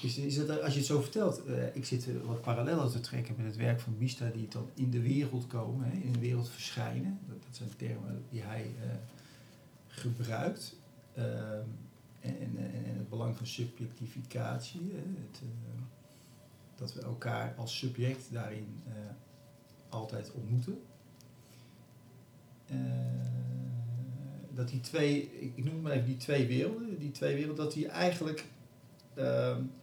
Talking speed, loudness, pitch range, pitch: 155 wpm, -37 LUFS, 115-140 Hz, 125 Hz